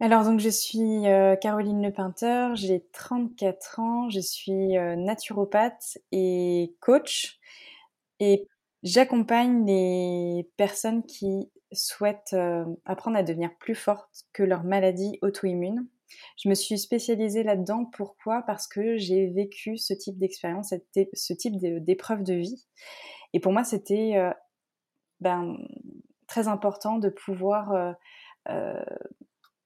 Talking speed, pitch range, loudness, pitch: 115 wpm, 190-230 Hz, -27 LUFS, 205 Hz